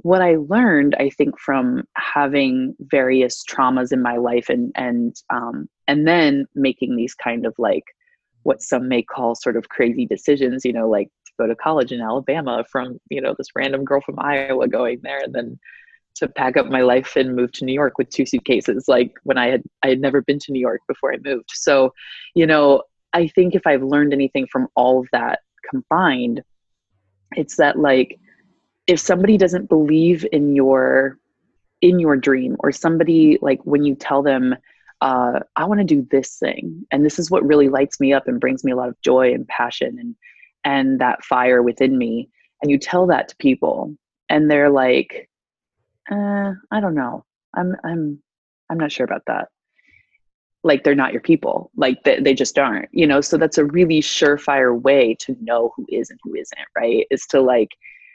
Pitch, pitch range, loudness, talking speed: 140 Hz, 130-170 Hz, -18 LUFS, 195 wpm